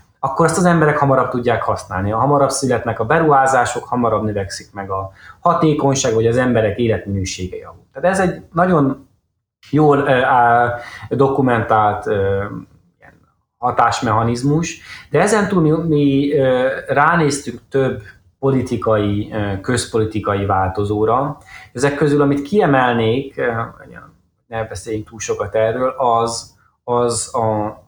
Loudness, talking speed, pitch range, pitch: -17 LUFS, 120 wpm, 105-140 Hz, 120 Hz